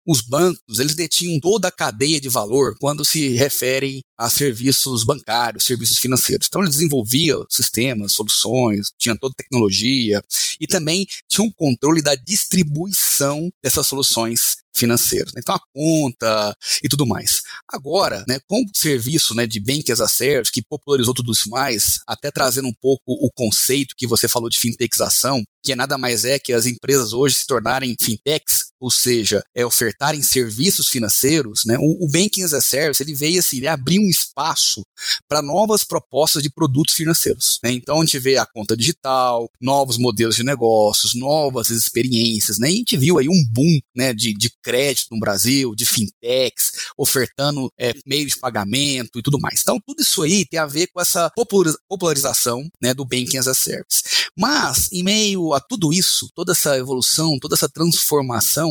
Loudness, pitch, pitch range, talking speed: -17 LUFS, 135 Hz, 120-160 Hz, 175 wpm